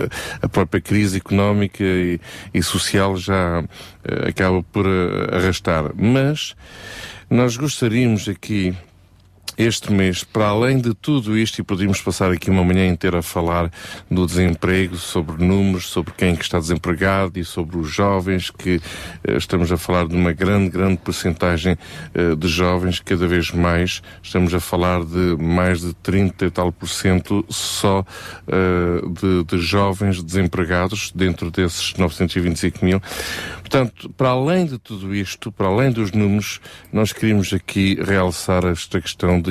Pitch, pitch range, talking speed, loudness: 95 Hz, 90-100 Hz, 150 wpm, -19 LUFS